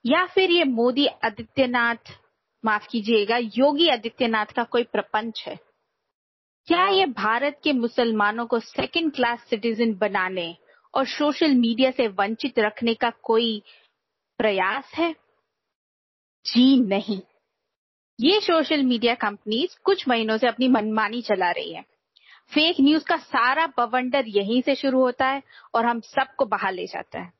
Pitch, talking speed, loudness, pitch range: 245 Hz, 140 wpm, -22 LUFS, 225-295 Hz